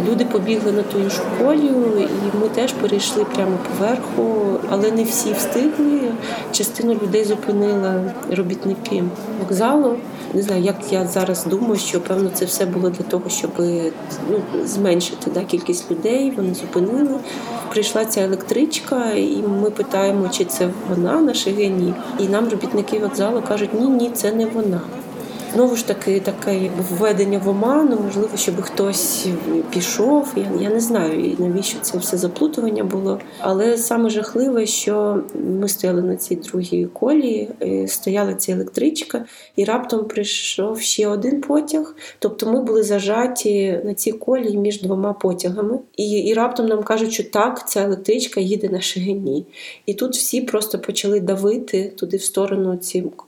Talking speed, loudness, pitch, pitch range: 150 wpm, -19 LUFS, 210 Hz, 195-230 Hz